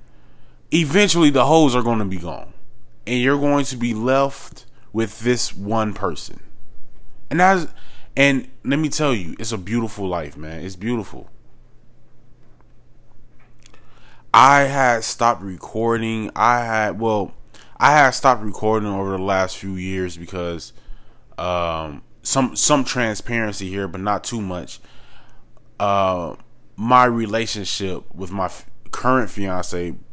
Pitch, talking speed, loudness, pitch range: 115 Hz, 130 wpm, -19 LUFS, 95-125 Hz